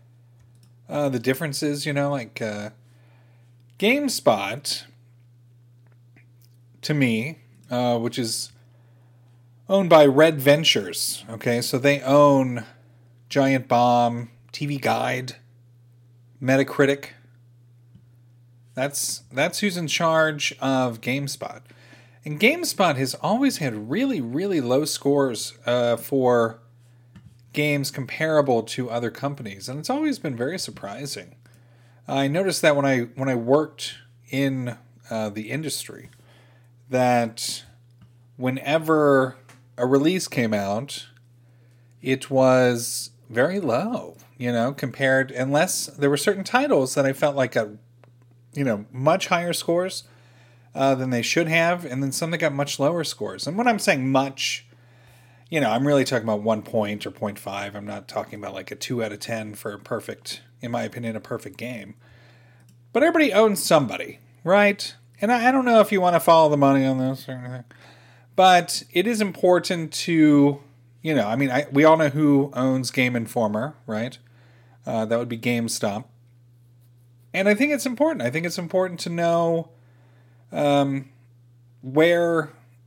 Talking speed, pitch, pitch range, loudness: 145 wpm, 125 Hz, 120-145 Hz, -22 LUFS